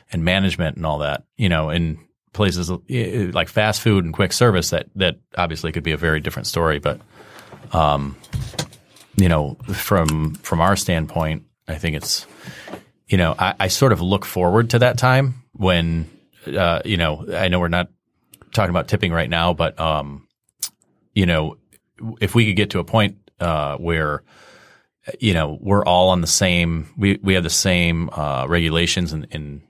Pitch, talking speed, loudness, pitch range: 85 Hz, 180 wpm, -19 LUFS, 80-100 Hz